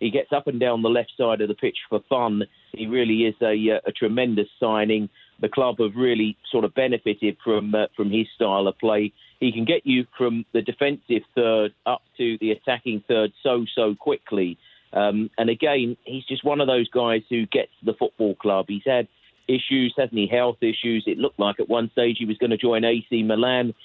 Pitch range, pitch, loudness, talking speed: 110-125 Hz, 115 Hz, -23 LUFS, 215 wpm